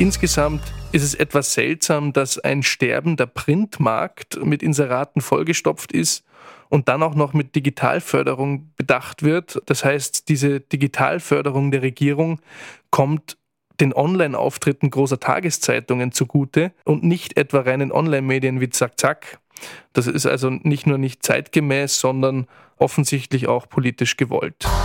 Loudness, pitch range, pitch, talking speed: -20 LUFS, 135-155 Hz, 145 Hz, 130 wpm